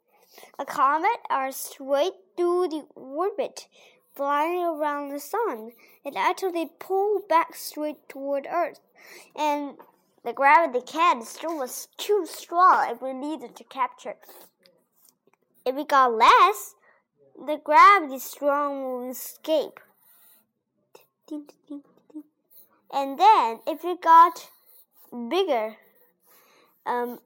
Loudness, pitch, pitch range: -23 LUFS, 305 Hz, 275-365 Hz